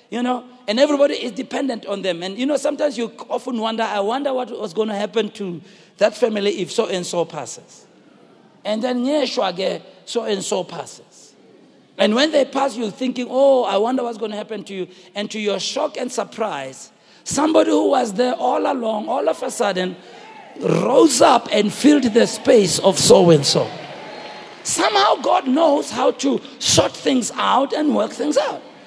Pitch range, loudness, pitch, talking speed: 200-260 Hz, -19 LUFS, 225 Hz, 175 wpm